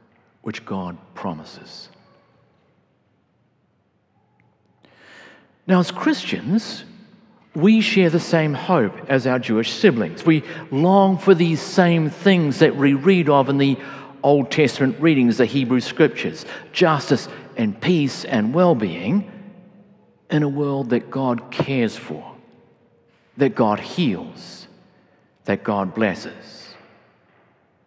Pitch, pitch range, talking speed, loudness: 160 Hz, 135-190 Hz, 110 wpm, -19 LUFS